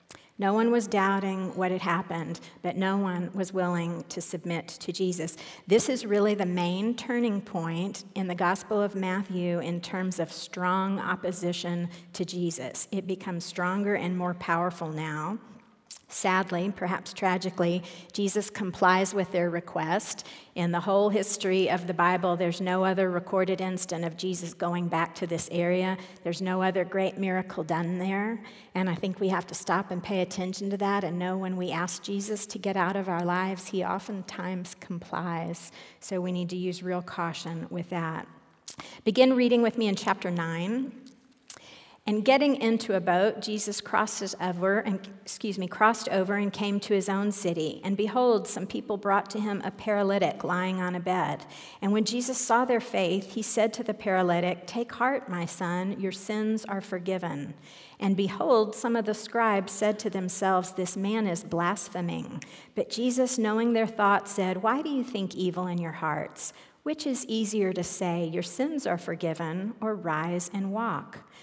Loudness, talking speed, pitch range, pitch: -28 LUFS, 175 wpm, 180-210 Hz, 190 Hz